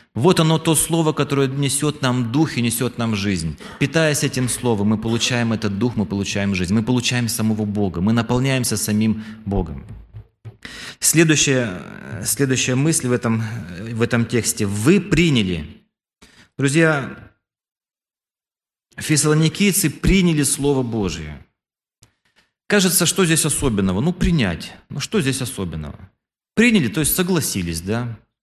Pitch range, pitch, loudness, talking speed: 110-155 Hz, 125 Hz, -19 LUFS, 125 wpm